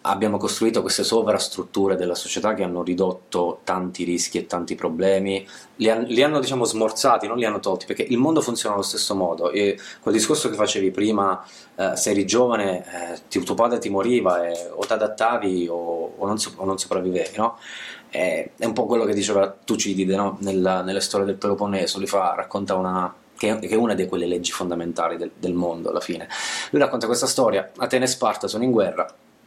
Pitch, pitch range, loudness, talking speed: 95 Hz, 90-110 Hz, -22 LUFS, 195 wpm